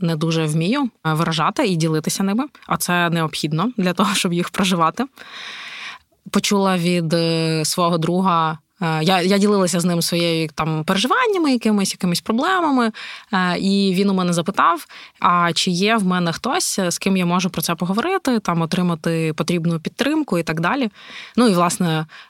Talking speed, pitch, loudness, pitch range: 155 wpm, 180 Hz, -19 LUFS, 170-205 Hz